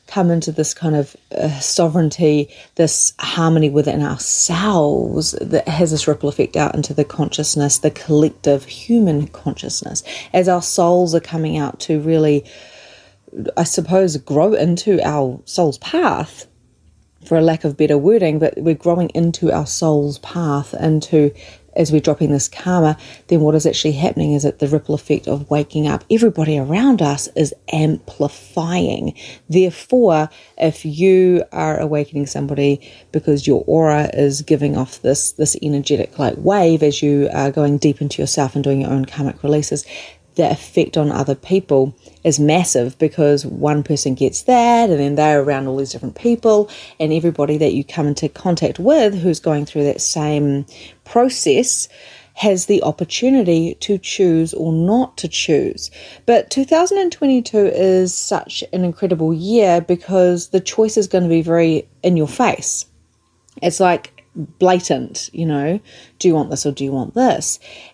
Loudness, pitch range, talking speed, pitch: -16 LUFS, 145-175 Hz, 160 wpm, 155 Hz